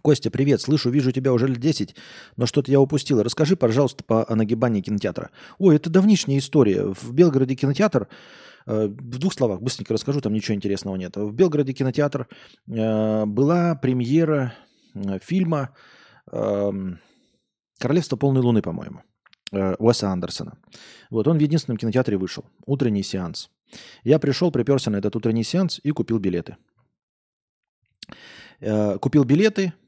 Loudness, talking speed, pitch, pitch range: -22 LUFS, 145 wpm, 130 Hz, 110-150 Hz